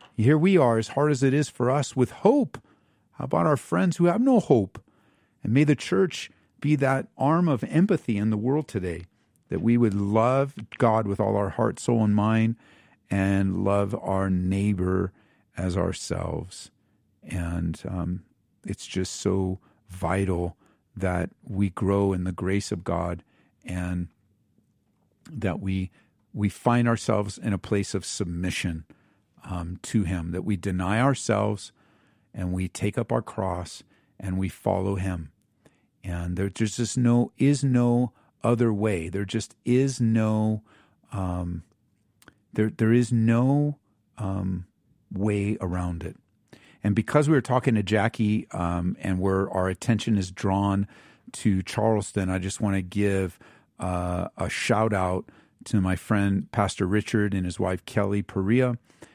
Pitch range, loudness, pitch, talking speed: 95-115 Hz, -26 LUFS, 100 Hz, 150 wpm